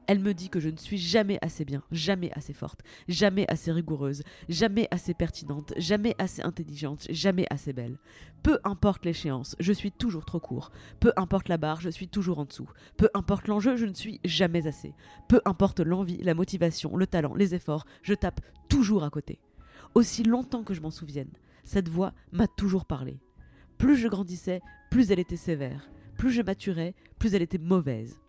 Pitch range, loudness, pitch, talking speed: 155-200 Hz, -28 LUFS, 180 Hz, 190 wpm